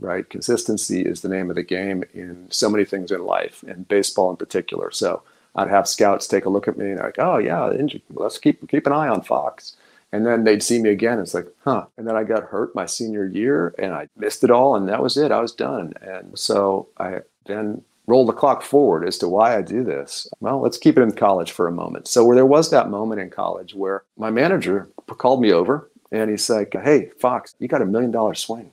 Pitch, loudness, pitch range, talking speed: 105 Hz, -20 LUFS, 95-110 Hz, 240 wpm